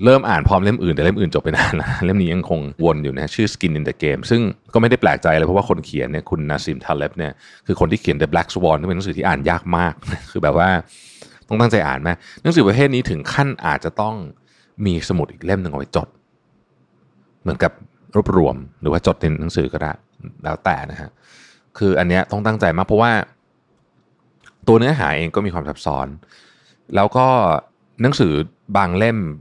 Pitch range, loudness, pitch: 80-110 Hz, -18 LUFS, 95 Hz